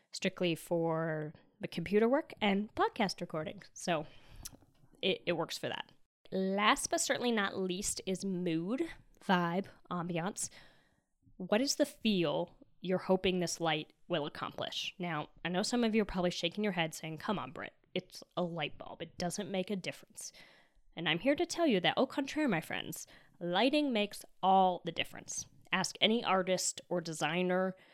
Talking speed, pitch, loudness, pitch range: 170 wpm, 185 Hz, -34 LUFS, 170-210 Hz